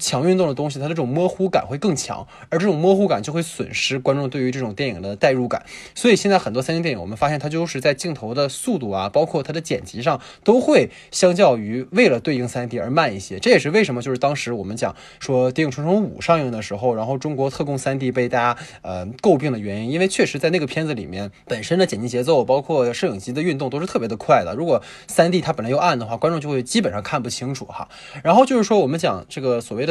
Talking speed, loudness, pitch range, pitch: 385 characters per minute, -20 LUFS, 125-170 Hz, 140 Hz